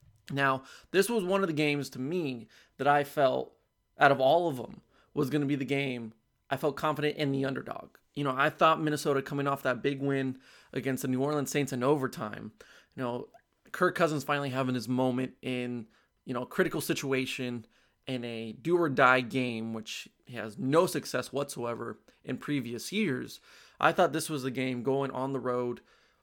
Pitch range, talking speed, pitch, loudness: 125-150 Hz, 190 wpm, 135 Hz, -30 LUFS